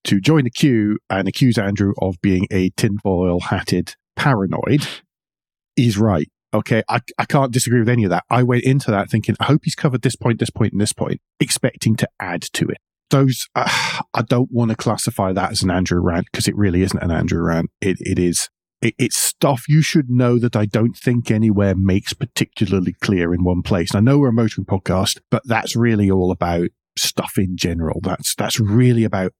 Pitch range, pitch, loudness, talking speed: 95-120 Hz, 110 Hz, -18 LUFS, 210 wpm